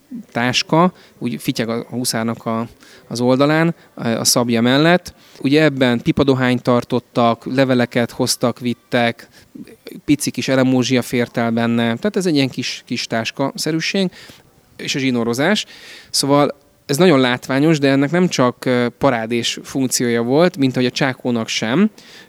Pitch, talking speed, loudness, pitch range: 130 Hz, 135 wpm, -17 LUFS, 120-145 Hz